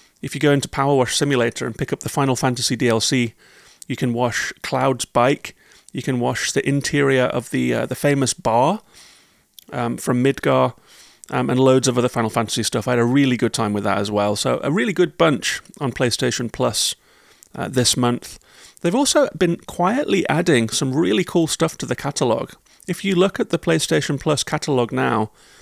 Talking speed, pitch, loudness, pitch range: 195 wpm, 130 Hz, -19 LUFS, 120-150 Hz